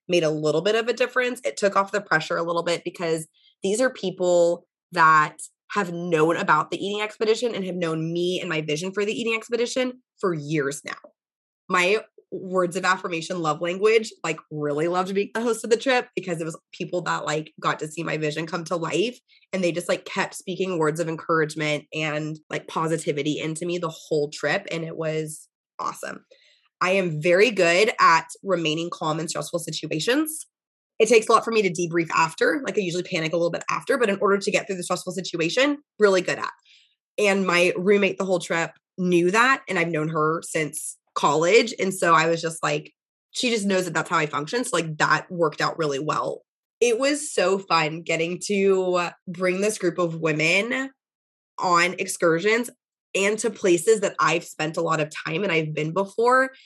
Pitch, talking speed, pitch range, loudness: 180 Hz, 200 wpm, 160-210 Hz, -23 LUFS